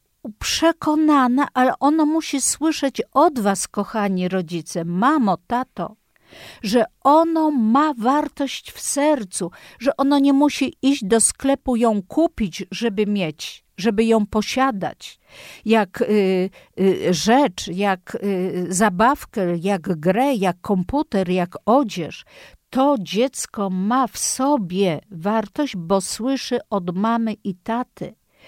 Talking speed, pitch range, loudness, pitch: 120 wpm, 195-275 Hz, -20 LUFS, 225 Hz